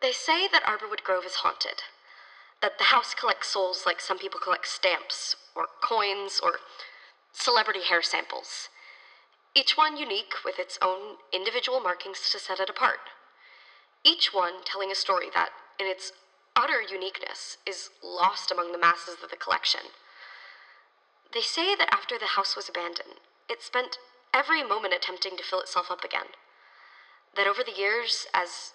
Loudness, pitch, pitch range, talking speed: -27 LUFS, 215 Hz, 190-310 Hz, 160 wpm